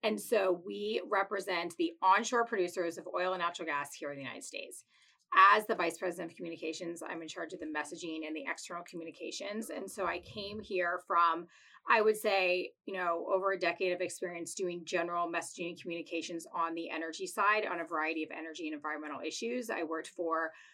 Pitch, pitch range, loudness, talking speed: 175 Hz, 165-195 Hz, -34 LUFS, 200 wpm